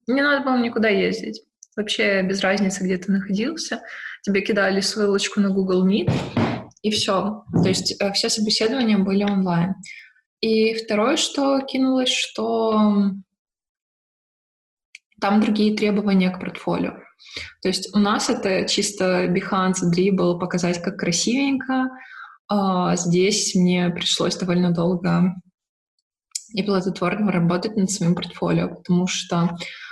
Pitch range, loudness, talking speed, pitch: 185-220 Hz, -21 LUFS, 120 wpm, 200 Hz